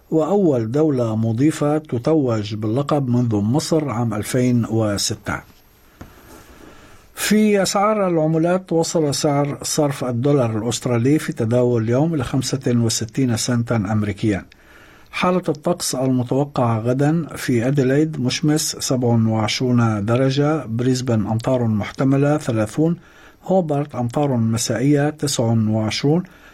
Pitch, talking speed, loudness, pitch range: 130 Hz, 95 wpm, -19 LUFS, 115-155 Hz